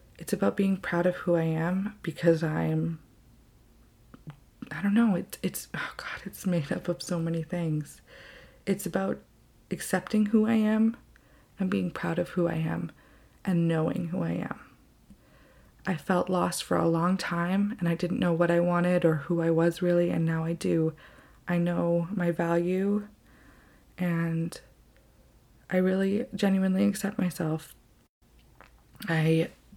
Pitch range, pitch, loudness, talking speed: 165-190 Hz, 175 Hz, -28 LUFS, 155 wpm